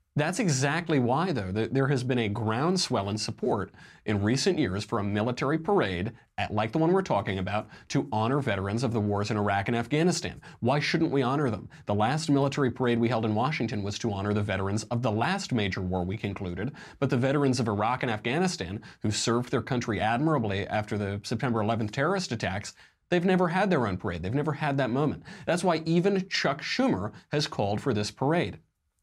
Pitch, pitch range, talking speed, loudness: 120 Hz, 105-150 Hz, 205 wpm, -28 LUFS